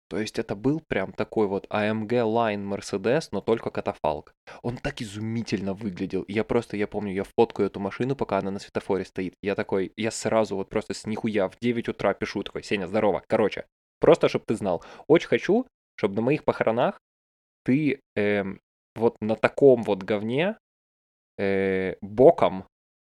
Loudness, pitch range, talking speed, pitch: -26 LUFS, 95-115 Hz, 170 wpm, 105 Hz